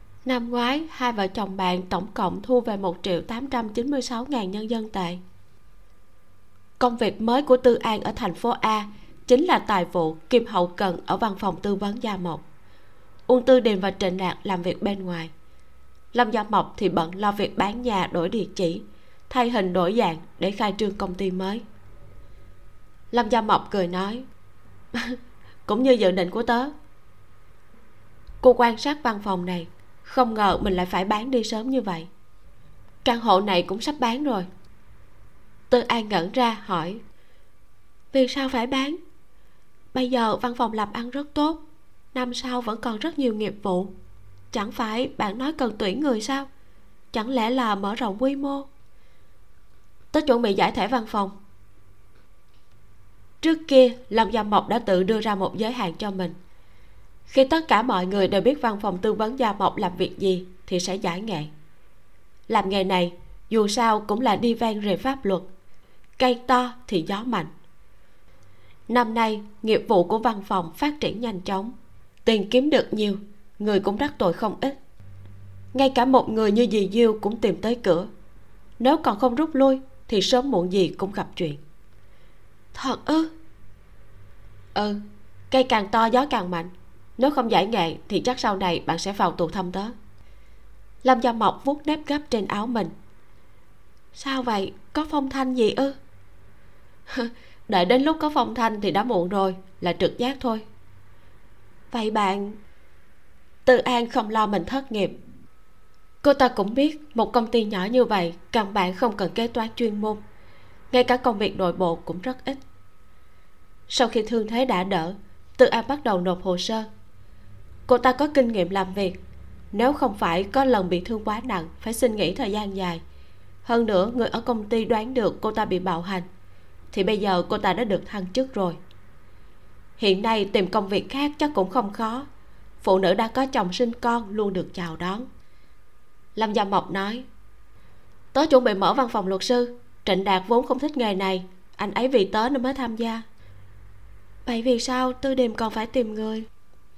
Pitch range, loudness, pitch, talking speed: 180-245 Hz, -24 LUFS, 210 Hz, 185 wpm